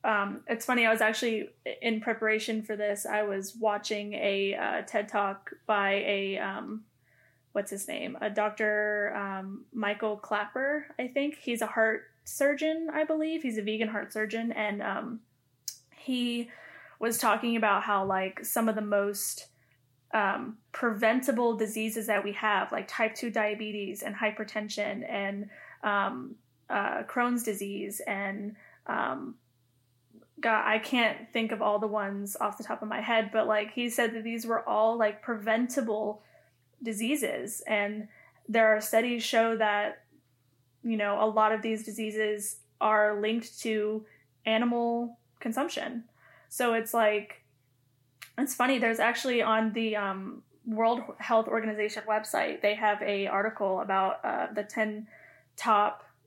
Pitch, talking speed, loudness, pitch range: 215 Hz, 145 wpm, -30 LUFS, 205-230 Hz